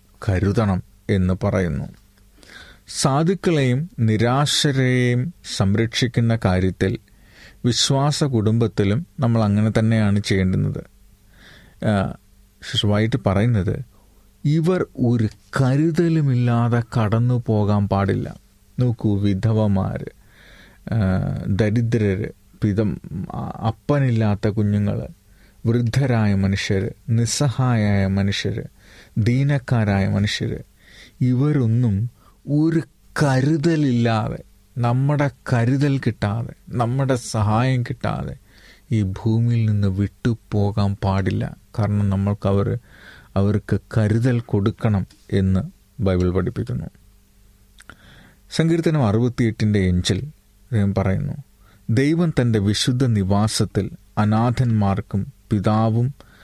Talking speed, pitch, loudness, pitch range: 70 wpm, 110 Hz, -20 LUFS, 100-125 Hz